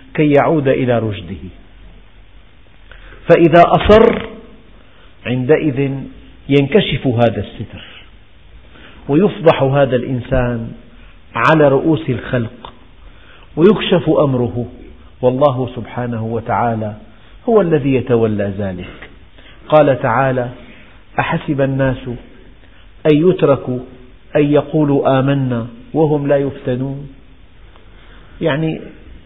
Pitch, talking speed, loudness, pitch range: 125 Hz, 80 wpm, -14 LUFS, 110-145 Hz